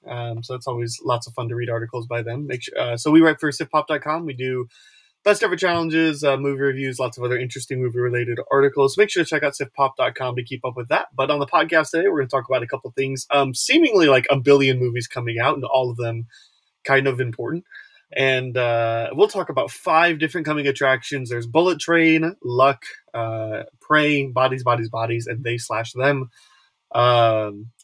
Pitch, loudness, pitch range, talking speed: 130 Hz, -20 LUFS, 120-150 Hz, 210 wpm